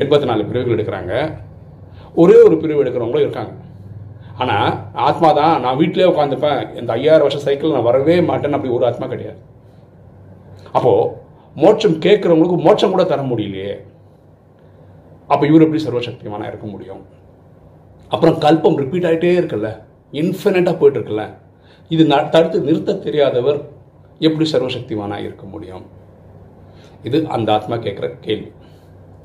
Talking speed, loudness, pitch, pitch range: 125 wpm, -15 LUFS, 125 Hz, 100-160 Hz